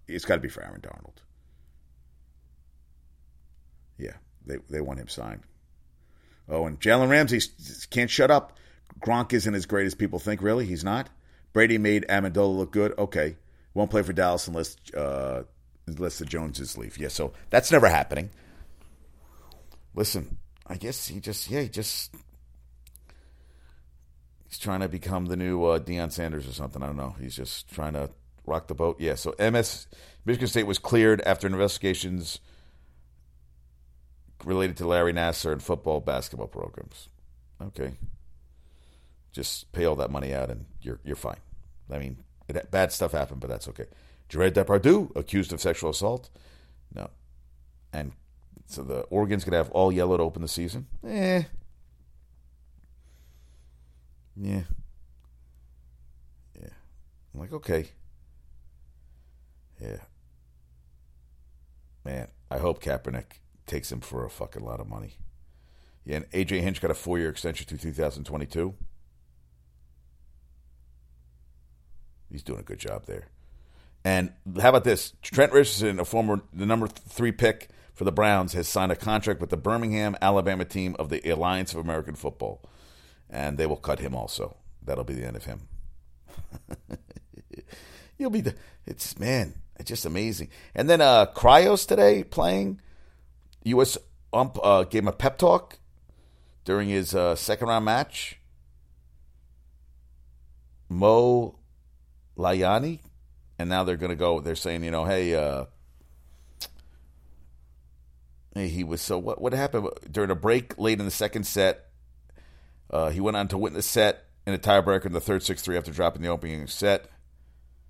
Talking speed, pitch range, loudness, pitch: 150 wpm, 65-95 Hz, -26 LUFS, 70 Hz